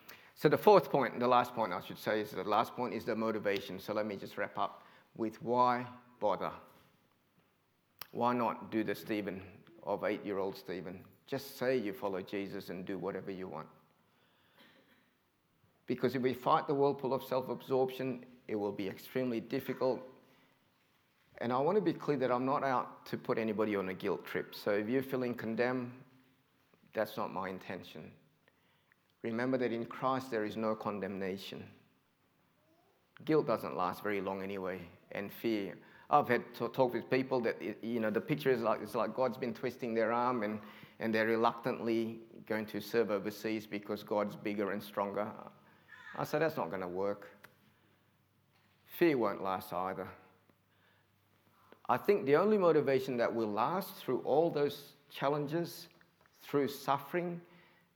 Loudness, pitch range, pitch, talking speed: -35 LUFS, 100-130 Hz, 115 Hz, 165 wpm